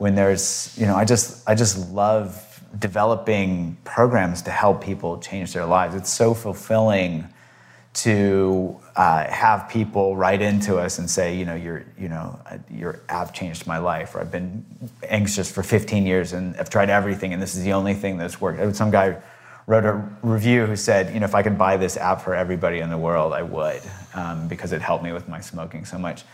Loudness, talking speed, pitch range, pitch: -21 LUFS, 205 wpm, 90-105 Hz, 95 Hz